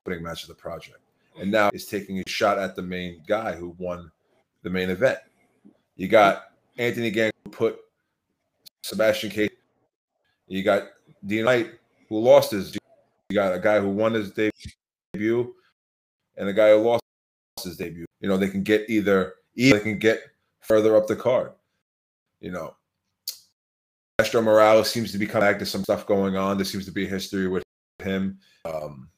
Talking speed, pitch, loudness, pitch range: 175 wpm, 100 Hz, -23 LUFS, 90-110 Hz